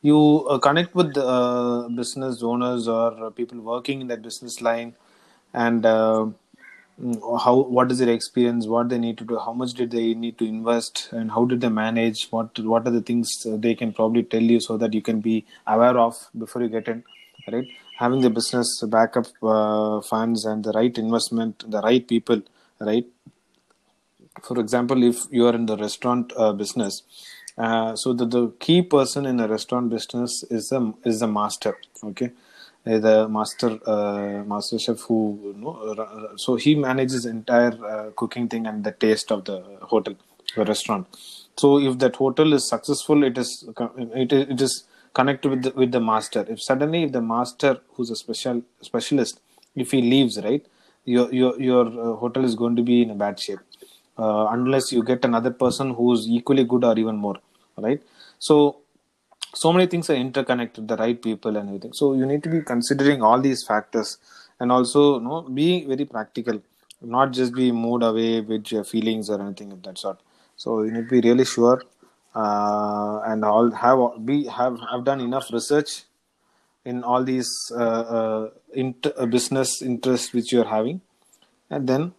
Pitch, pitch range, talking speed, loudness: 120 Hz, 115-130 Hz, 180 wpm, -22 LUFS